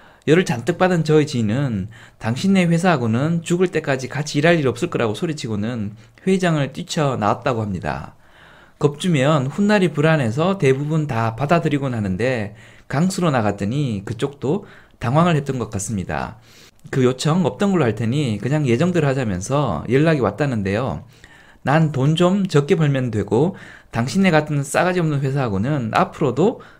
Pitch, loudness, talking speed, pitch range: 140 Hz, -19 LUFS, 335 characters per minute, 115-165 Hz